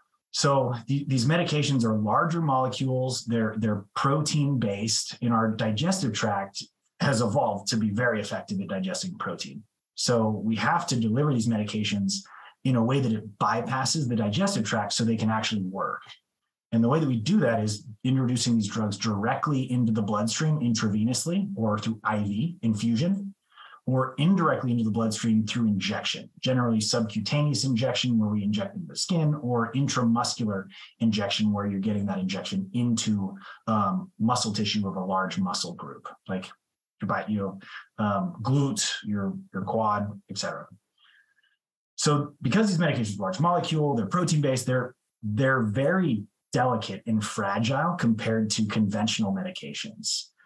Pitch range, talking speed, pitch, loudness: 110-150 Hz, 150 wpm, 120 Hz, -26 LUFS